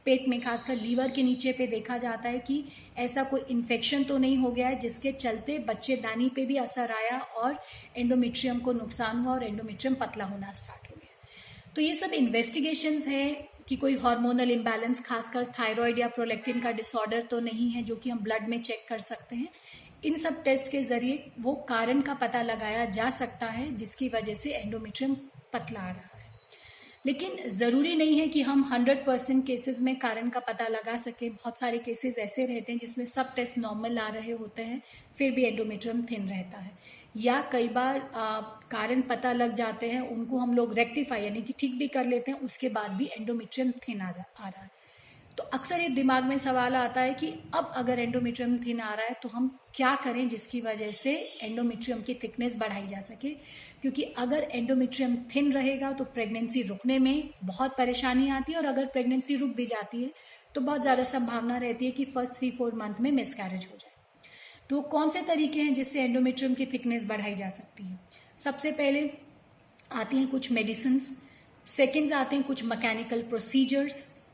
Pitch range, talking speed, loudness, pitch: 230-265 Hz, 195 wpm, -29 LUFS, 245 Hz